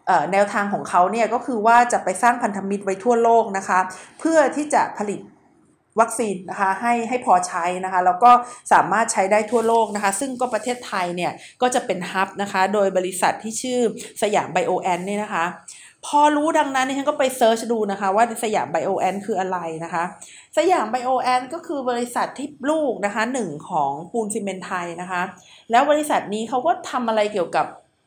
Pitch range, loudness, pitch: 185-250 Hz, -21 LUFS, 220 Hz